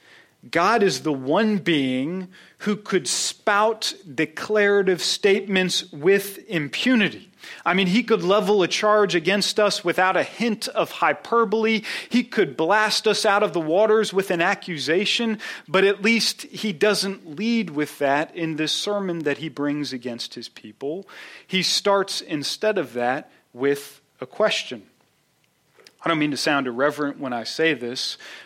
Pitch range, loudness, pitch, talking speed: 155-210 Hz, -22 LUFS, 190 Hz, 150 wpm